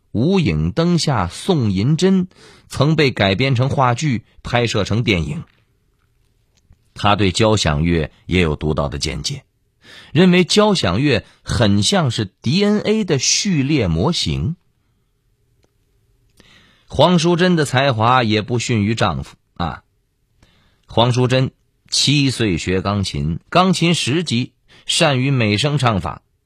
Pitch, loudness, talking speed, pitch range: 120 Hz, -17 LUFS, 175 characters per minute, 100-150 Hz